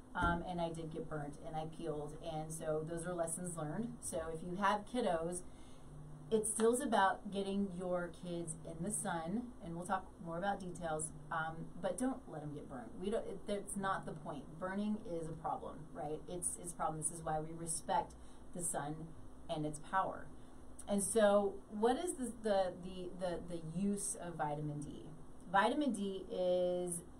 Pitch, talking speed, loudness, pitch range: 175 Hz, 190 wpm, -40 LUFS, 160-195 Hz